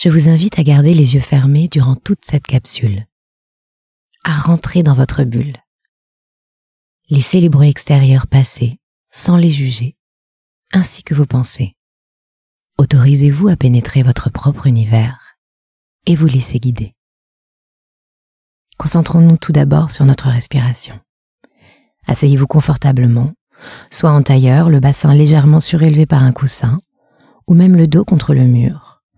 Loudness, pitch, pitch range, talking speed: -11 LUFS, 140 Hz, 125-155 Hz, 130 wpm